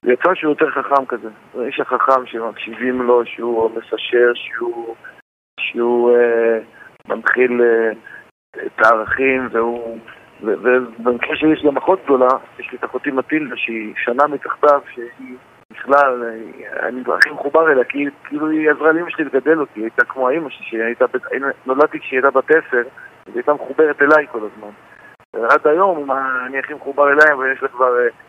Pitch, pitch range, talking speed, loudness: 130 Hz, 120-145 Hz, 170 wpm, -16 LUFS